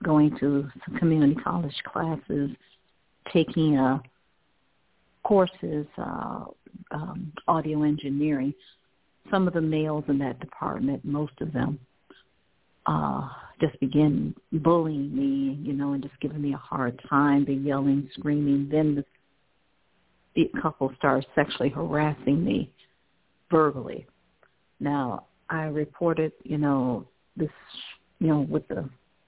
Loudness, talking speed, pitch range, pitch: -27 LUFS, 120 wpm, 135-155 Hz, 145 Hz